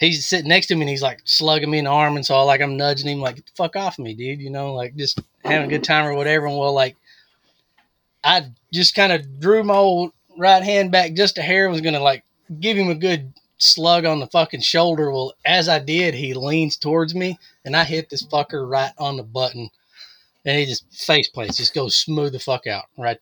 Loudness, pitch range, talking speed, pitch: -18 LUFS, 135-170 Hz, 245 wpm, 150 Hz